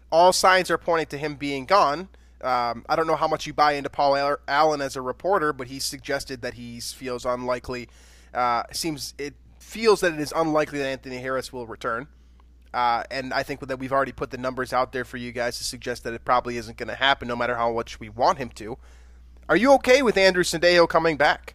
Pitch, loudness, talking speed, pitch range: 135 Hz, -23 LUFS, 230 wpm, 120-155 Hz